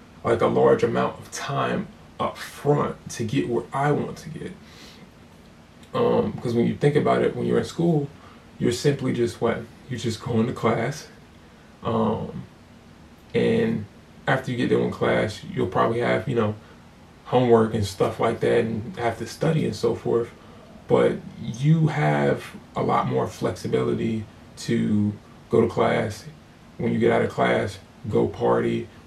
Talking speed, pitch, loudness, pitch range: 165 wpm, 115 Hz, -24 LUFS, 80-120 Hz